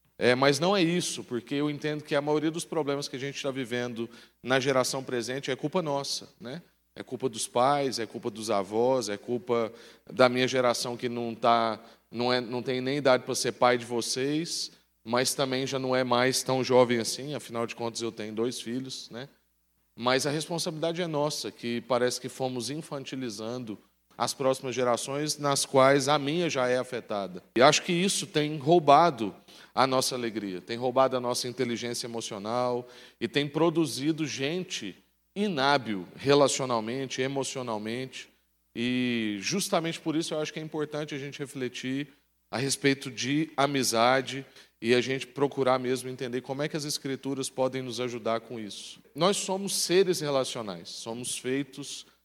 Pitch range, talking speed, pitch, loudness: 120-145 Hz, 170 wpm, 130 Hz, -28 LUFS